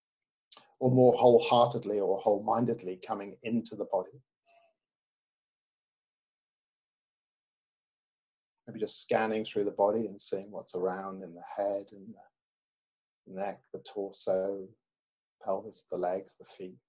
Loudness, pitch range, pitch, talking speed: -30 LUFS, 95-125 Hz, 100 Hz, 115 wpm